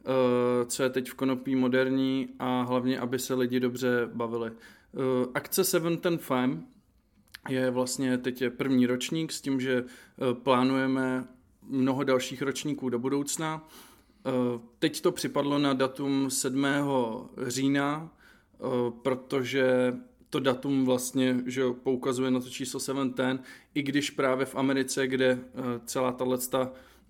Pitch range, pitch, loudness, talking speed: 125-135 Hz, 130 Hz, -29 LUFS, 125 wpm